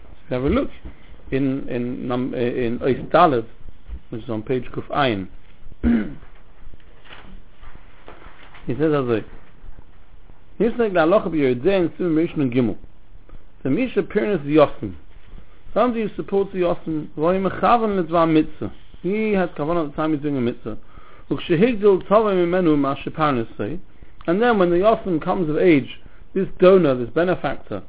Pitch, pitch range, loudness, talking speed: 150 Hz, 115-180 Hz, -20 LUFS, 145 wpm